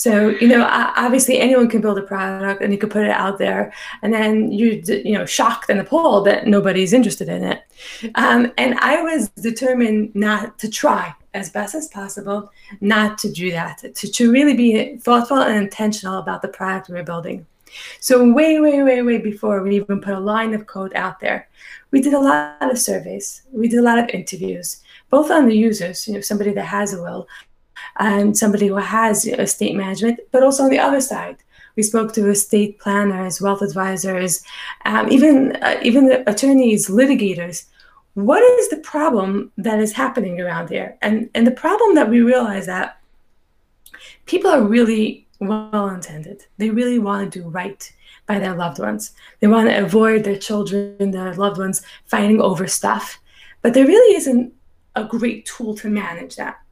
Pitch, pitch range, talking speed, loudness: 215 Hz, 200-245 Hz, 190 wpm, -17 LUFS